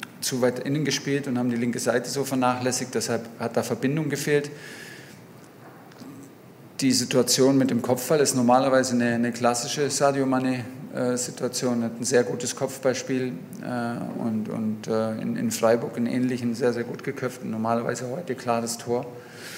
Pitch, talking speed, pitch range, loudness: 125 Hz, 145 wpm, 120-135 Hz, -25 LUFS